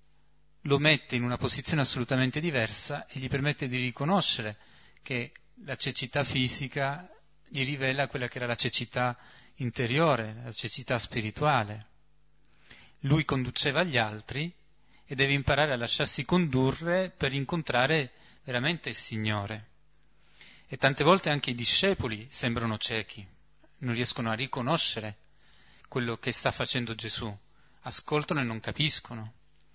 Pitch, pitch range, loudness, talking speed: 130 Hz, 115-145 Hz, -29 LUFS, 125 wpm